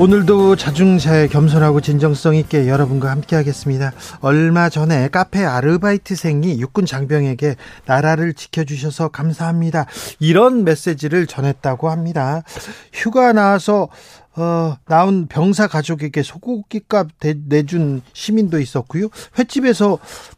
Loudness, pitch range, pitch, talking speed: -16 LUFS, 145-185 Hz, 160 Hz, 305 characters per minute